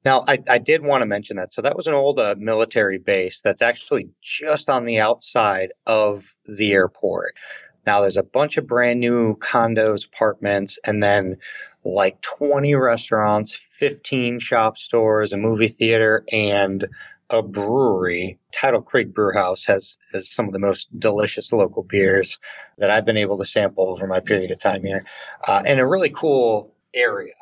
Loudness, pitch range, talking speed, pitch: -20 LUFS, 100-120 Hz, 170 wpm, 110 Hz